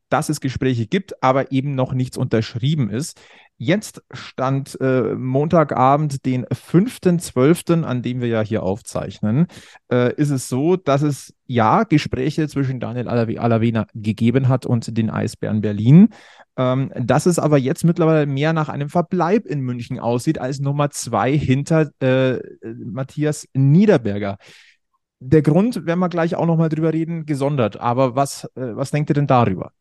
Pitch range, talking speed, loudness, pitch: 125-155 Hz, 155 wpm, -19 LUFS, 135 Hz